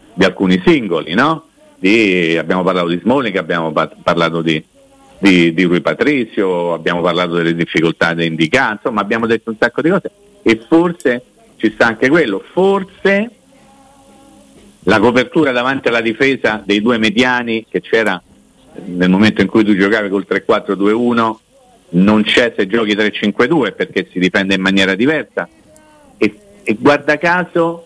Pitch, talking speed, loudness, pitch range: 105 Hz, 150 wpm, -14 LUFS, 90-125 Hz